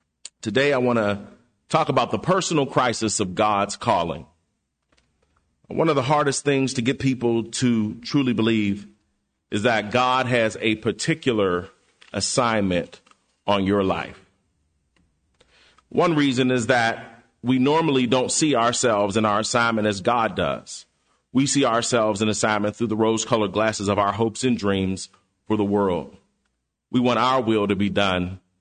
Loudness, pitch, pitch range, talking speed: -22 LUFS, 110 Hz, 100-130 Hz, 150 wpm